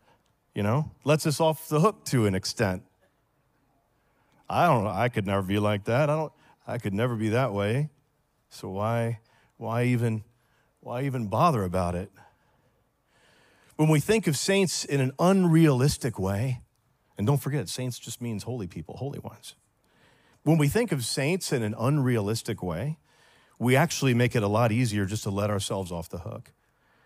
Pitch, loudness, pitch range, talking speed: 125 Hz, -26 LUFS, 105-145 Hz, 175 wpm